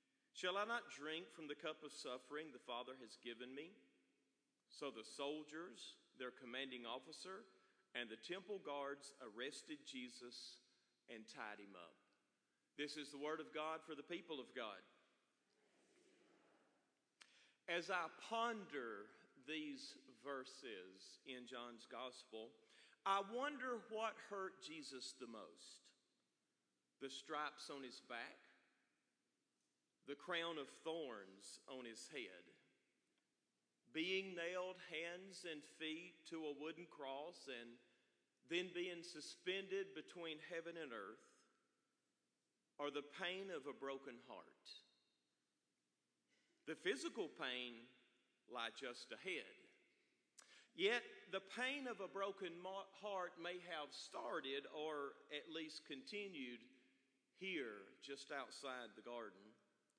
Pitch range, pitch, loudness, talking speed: 130-190 Hz, 155 Hz, -50 LUFS, 115 wpm